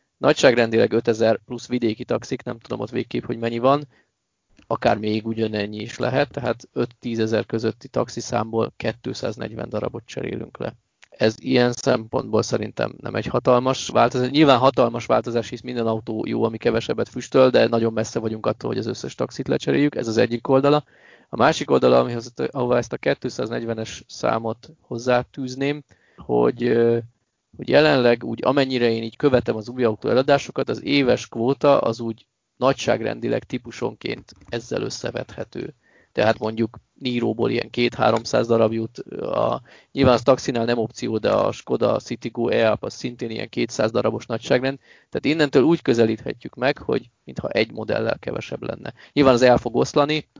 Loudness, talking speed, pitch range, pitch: -22 LUFS, 155 wpm, 115-130 Hz, 120 Hz